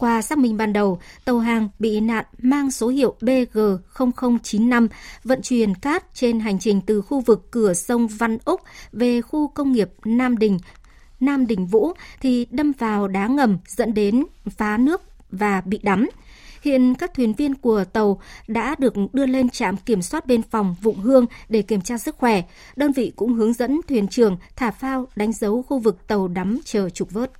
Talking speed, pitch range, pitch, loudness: 190 wpm, 210-255 Hz, 230 Hz, -21 LUFS